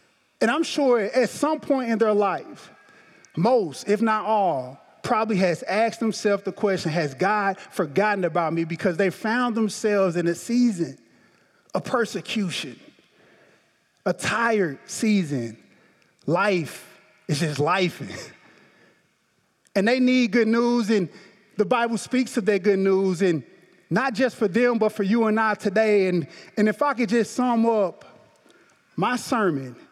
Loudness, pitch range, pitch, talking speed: -23 LUFS, 185-235 Hz, 210 Hz, 150 wpm